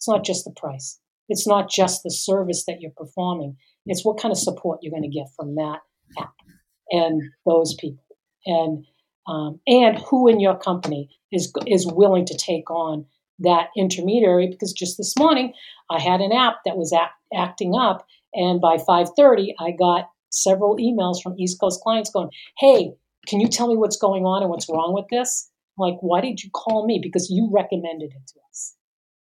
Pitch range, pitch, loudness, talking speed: 165-205 Hz, 180 Hz, -20 LUFS, 190 wpm